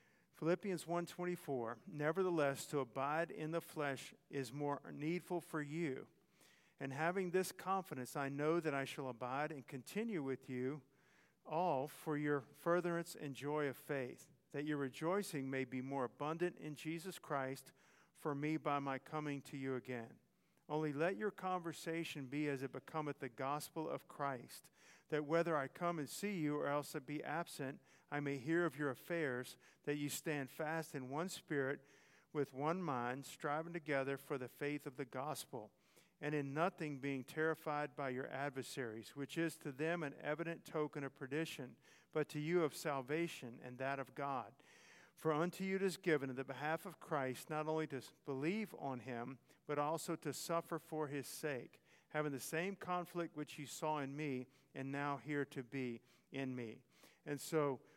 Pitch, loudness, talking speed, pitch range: 150 Hz, -43 LUFS, 175 wpm, 135-165 Hz